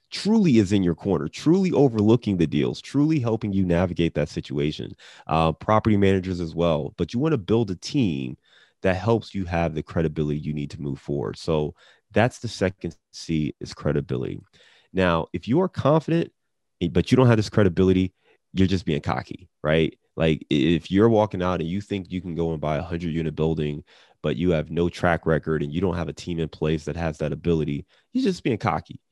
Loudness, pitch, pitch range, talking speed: -24 LUFS, 85 Hz, 80-105 Hz, 205 wpm